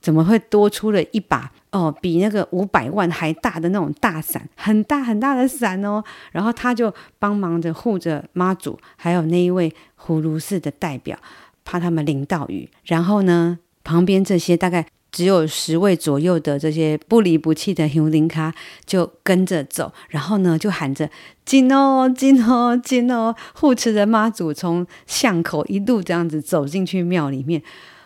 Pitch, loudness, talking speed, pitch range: 180 Hz, -19 LUFS, 250 characters per minute, 160-210 Hz